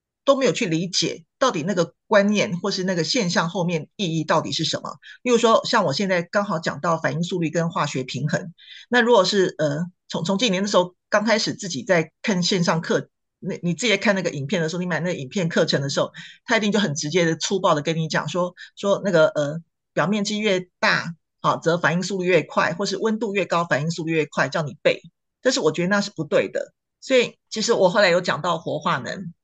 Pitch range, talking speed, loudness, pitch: 165-205 Hz, 330 characters per minute, -22 LUFS, 180 Hz